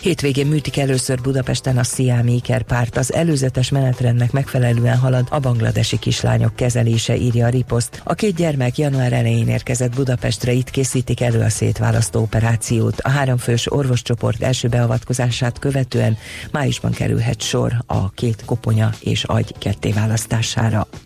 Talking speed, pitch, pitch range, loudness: 135 wpm, 125 Hz, 115-130 Hz, -18 LUFS